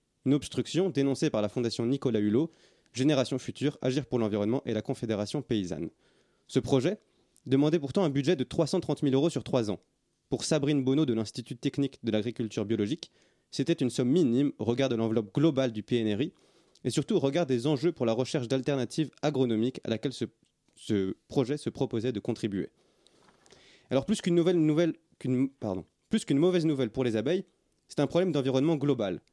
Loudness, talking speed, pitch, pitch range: -29 LUFS, 180 wpm, 135 Hz, 115-150 Hz